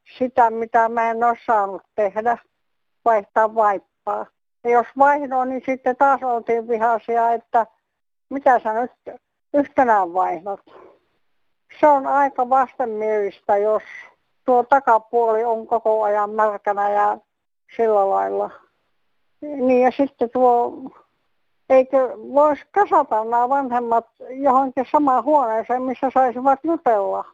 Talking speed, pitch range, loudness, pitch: 110 wpm, 220-265 Hz, -19 LUFS, 240 Hz